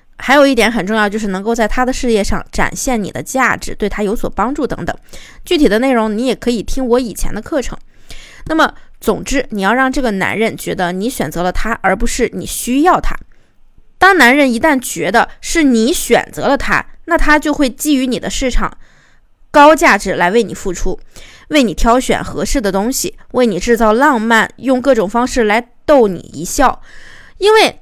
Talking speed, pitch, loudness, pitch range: 280 characters per minute, 240 Hz, -13 LUFS, 215-275 Hz